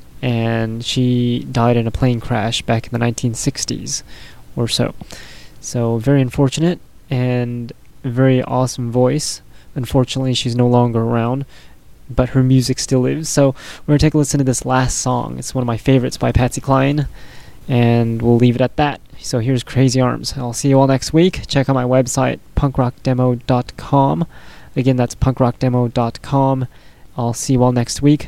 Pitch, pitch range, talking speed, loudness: 130 Hz, 120-135 Hz, 170 wpm, -17 LUFS